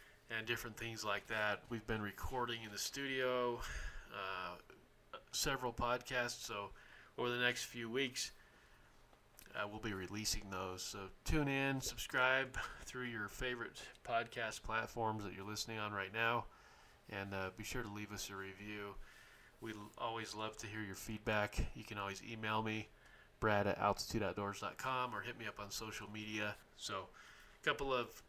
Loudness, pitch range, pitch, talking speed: -42 LUFS, 105-120 Hz, 110 Hz, 160 wpm